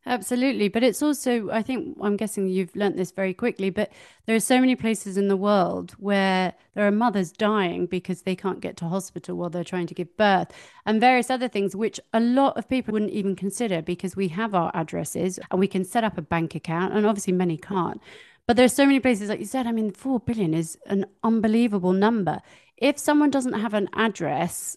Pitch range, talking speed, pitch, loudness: 185-235 Hz, 220 wpm, 205 Hz, -24 LUFS